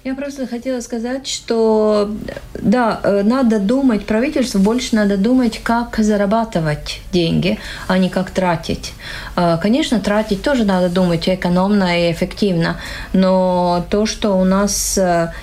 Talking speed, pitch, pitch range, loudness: 125 wpm, 205 Hz, 185-235 Hz, -16 LUFS